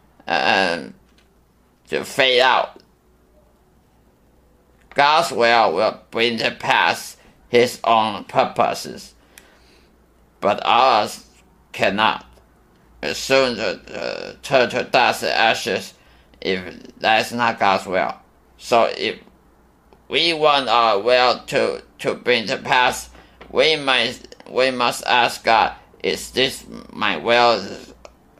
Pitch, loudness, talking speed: 120 Hz, -18 LUFS, 105 wpm